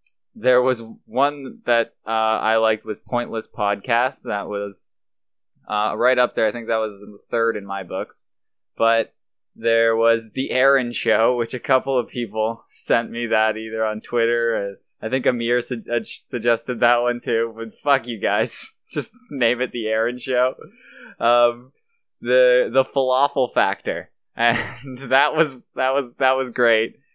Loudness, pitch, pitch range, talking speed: -21 LUFS, 120 Hz, 110-125 Hz, 165 wpm